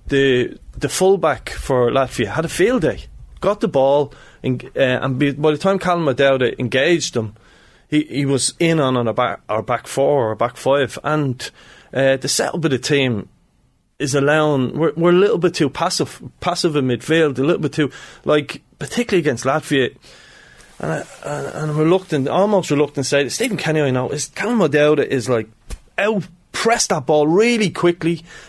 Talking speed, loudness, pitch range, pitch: 180 wpm, -18 LUFS, 130-165 Hz, 145 Hz